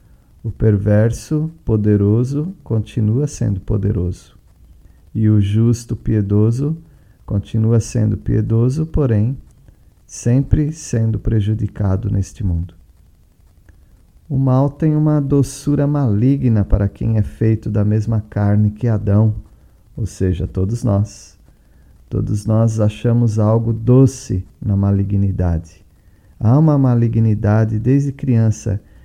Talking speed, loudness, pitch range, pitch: 105 wpm, -17 LUFS, 100-120 Hz, 110 Hz